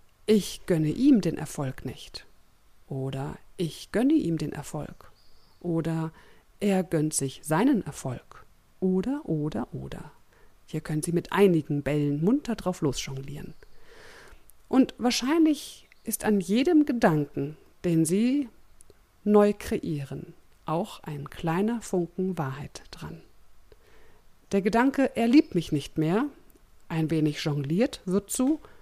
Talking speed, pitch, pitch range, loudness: 120 wpm, 180 Hz, 155-235 Hz, -27 LUFS